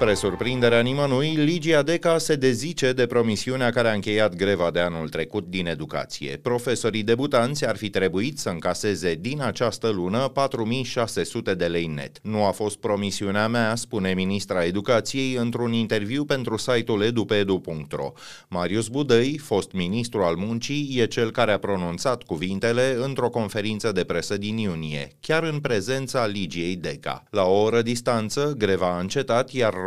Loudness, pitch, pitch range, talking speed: -24 LUFS, 115 Hz, 100-125 Hz, 155 wpm